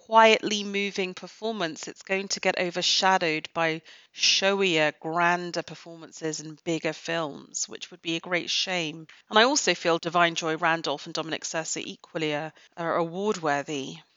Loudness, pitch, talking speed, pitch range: -26 LUFS, 170 Hz, 150 wpm, 160-185 Hz